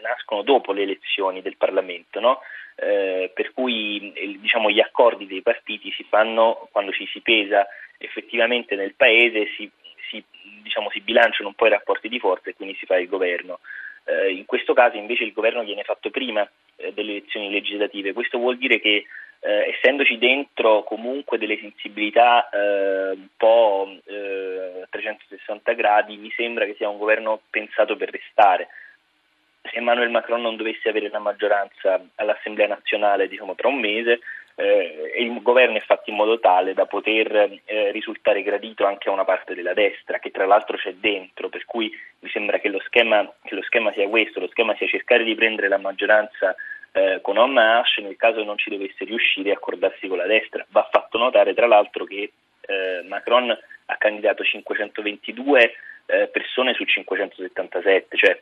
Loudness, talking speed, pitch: -21 LUFS, 175 wpm, 110 Hz